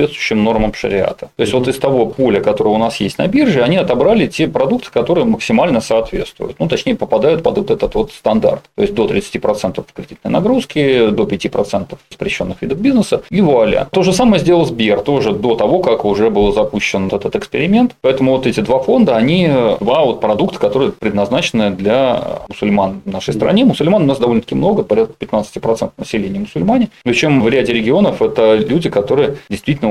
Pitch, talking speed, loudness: 130 Hz, 185 wpm, -14 LUFS